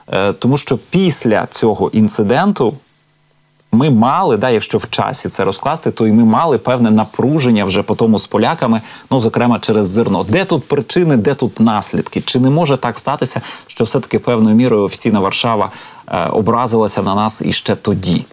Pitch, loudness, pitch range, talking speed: 115 Hz, -13 LUFS, 110-130 Hz, 170 wpm